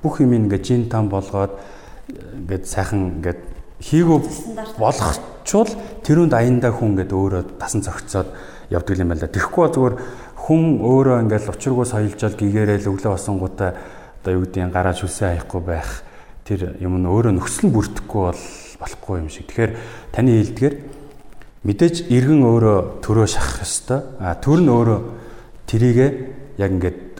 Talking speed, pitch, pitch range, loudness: 150 wpm, 105 Hz, 95-125 Hz, -19 LUFS